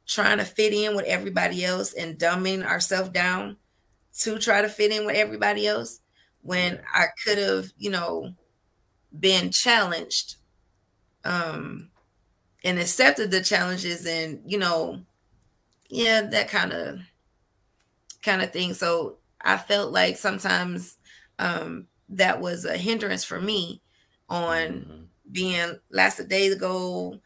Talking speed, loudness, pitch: 130 wpm, -23 LUFS, 175 Hz